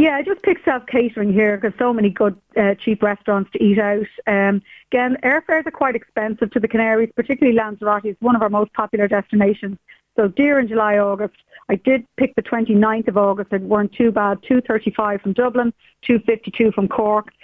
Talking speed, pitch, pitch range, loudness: 195 wpm, 220 Hz, 205-245 Hz, -18 LUFS